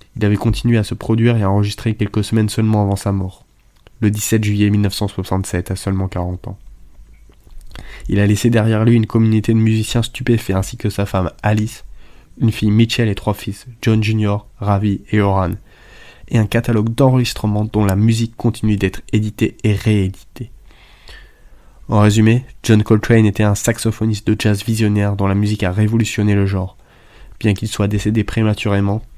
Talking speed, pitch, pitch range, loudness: 170 wpm, 105 Hz, 100-115 Hz, -16 LUFS